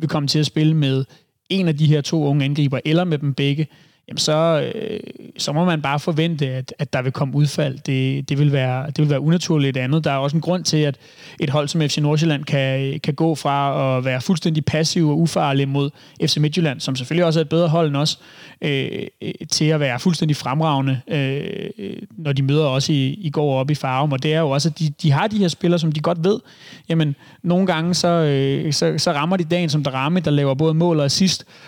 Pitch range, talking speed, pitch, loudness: 140-165 Hz, 235 wpm, 155 Hz, -19 LUFS